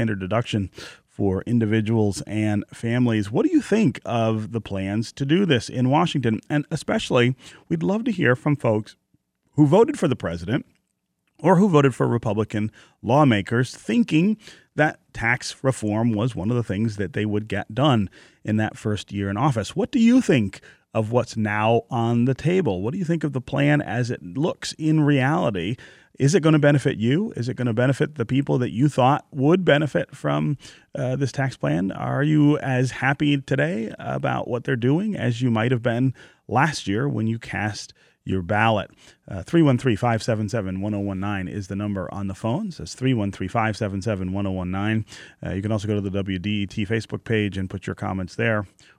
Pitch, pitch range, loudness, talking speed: 120 Hz, 105-145 Hz, -22 LUFS, 180 wpm